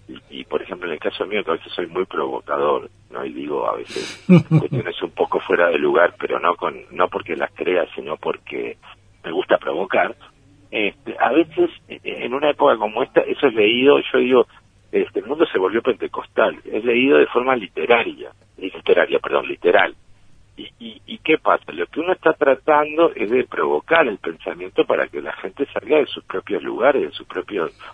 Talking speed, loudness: 195 wpm, -20 LUFS